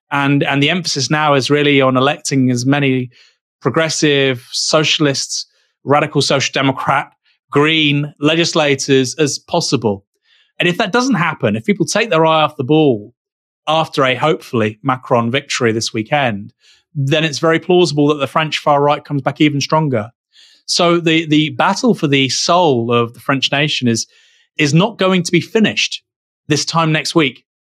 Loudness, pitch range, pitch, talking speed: -14 LUFS, 135-160 Hz, 150 Hz, 160 wpm